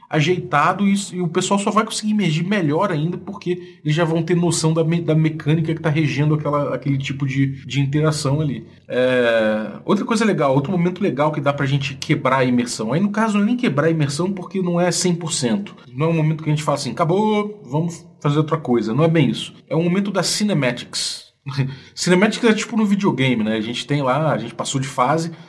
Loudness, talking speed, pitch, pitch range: -19 LUFS, 215 wpm, 160 Hz, 140-180 Hz